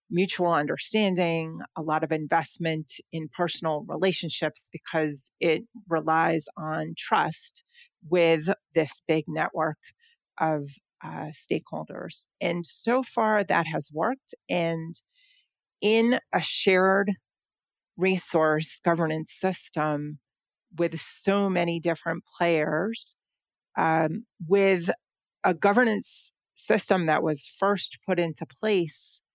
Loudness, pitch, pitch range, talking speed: -26 LUFS, 170 Hz, 160-200 Hz, 100 wpm